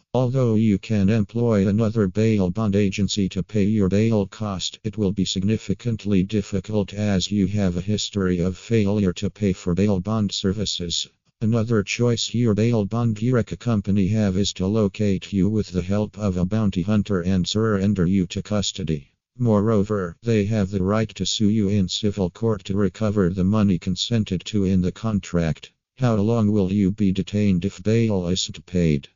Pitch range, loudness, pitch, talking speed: 95-110 Hz, -22 LUFS, 100 Hz, 175 wpm